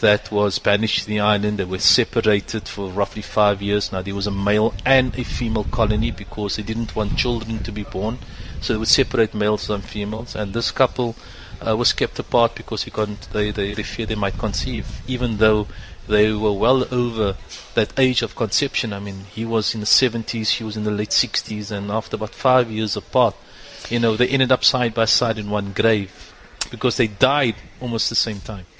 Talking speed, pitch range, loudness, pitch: 210 wpm, 105-115 Hz, -20 LUFS, 110 Hz